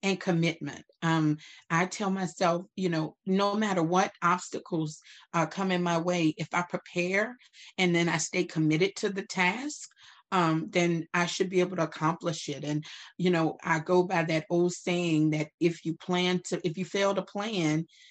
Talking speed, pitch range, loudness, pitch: 185 wpm, 165-185 Hz, -29 LUFS, 175 Hz